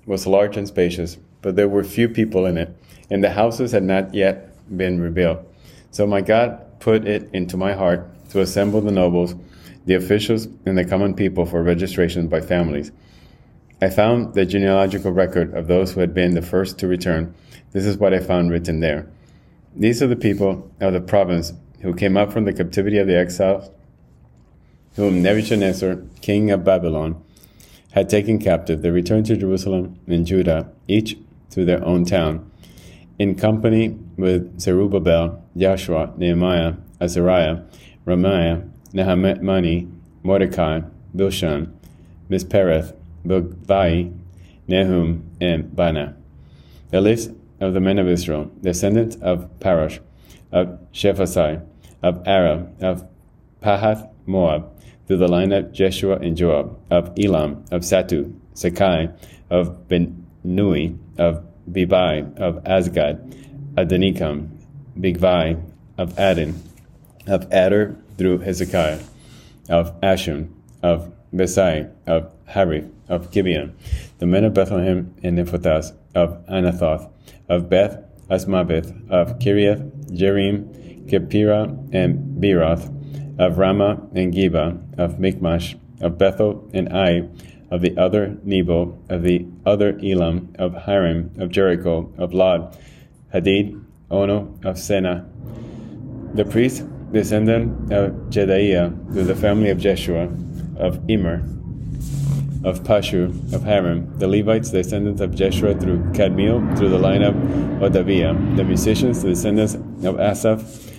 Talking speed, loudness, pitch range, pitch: 130 wpm, -19 LUFS, 85-100 Hz, 95 Hz